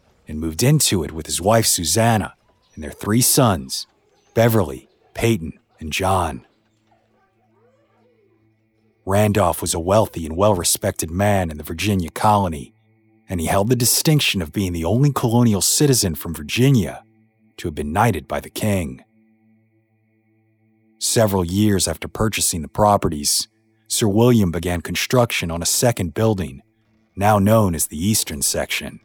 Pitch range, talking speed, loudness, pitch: 90-110 Hz, 140 wpm, -18 LUFS, 105 Hz